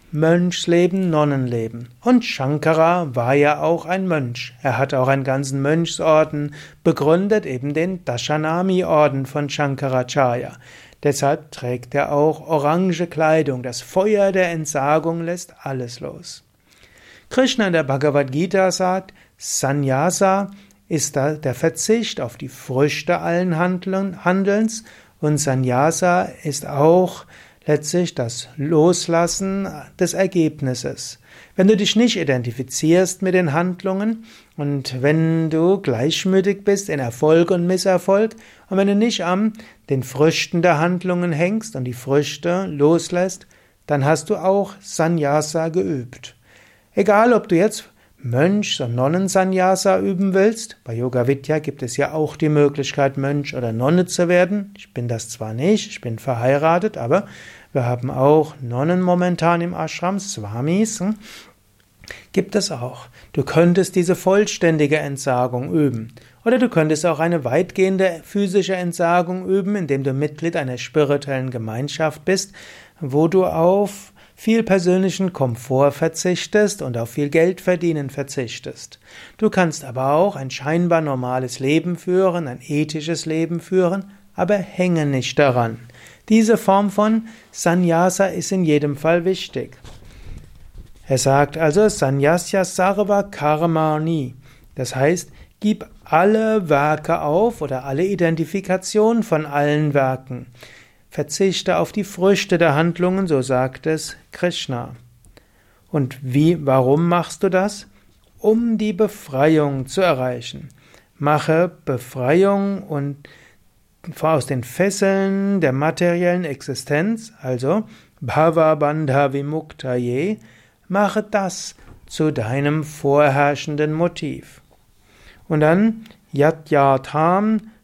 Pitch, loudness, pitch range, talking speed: 160 Hz, -19 LUFS, 135-185 Hz, 125 wpm